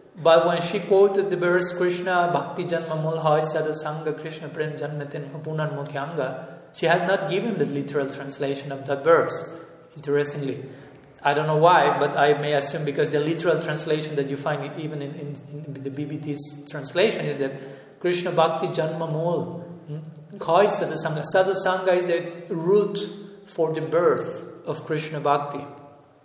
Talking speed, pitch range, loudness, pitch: 155 wpm, 145-170 Hz, -24 LUFS, 155 Hz